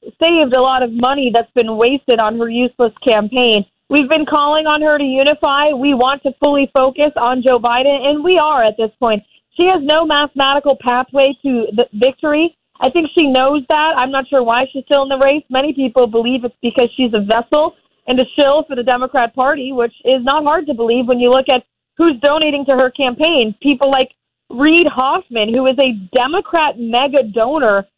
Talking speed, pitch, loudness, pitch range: 205 wpm, 265 Hz, -13 LUFS, 245-290 Hz